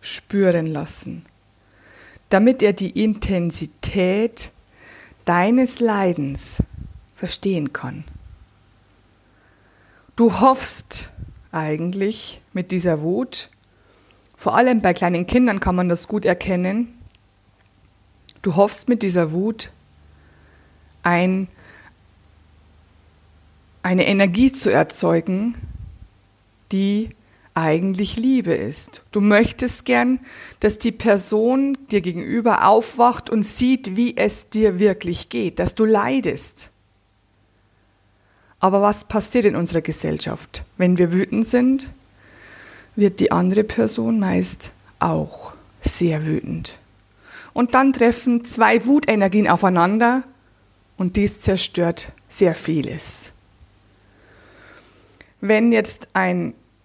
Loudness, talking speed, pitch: -19 LUFS, 95 wpm, 175 Hz